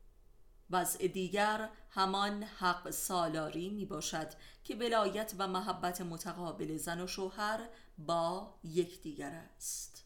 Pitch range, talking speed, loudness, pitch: 160-200 Hz, 105 wpm, -37 LUFS, 180 Hz